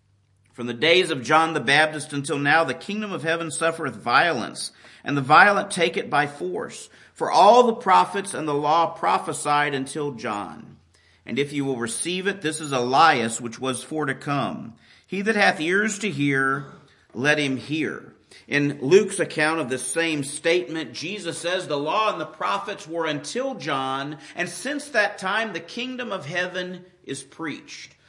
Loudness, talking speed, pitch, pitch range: -22 LUFS, 175 wpm, 155 Hz, 140-185 Hz